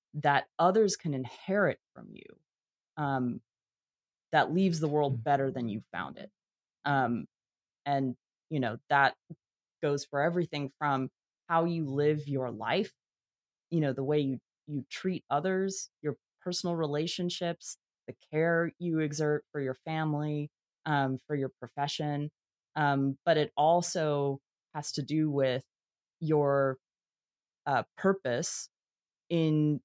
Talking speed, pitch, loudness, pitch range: 130 wpm, 150 Hz, -31 LUFS, 135-165 Hz